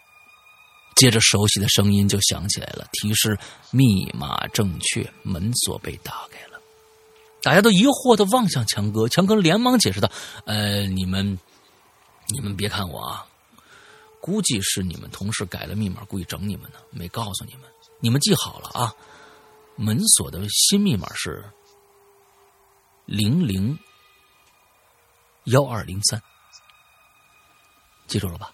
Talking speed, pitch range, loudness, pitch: 200 characters per minute, 100-150 Hz, -20 LUFS, 110 Hz